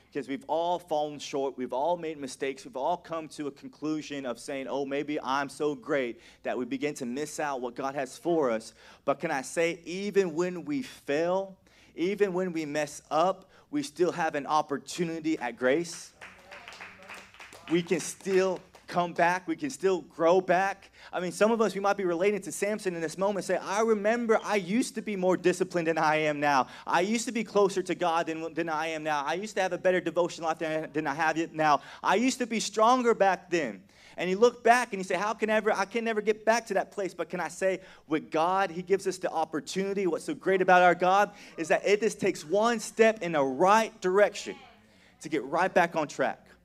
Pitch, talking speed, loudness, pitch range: 175 Hz, 225 wpm, -28 LUFS, 155-200 Hz